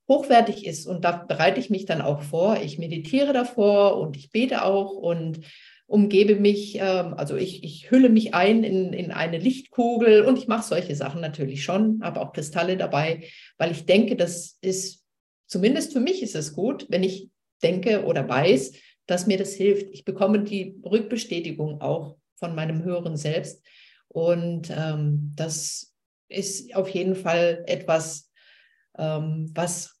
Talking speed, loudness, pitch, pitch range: 160 wpm, -23 LUFS, 180 Hz, 160-205 Hz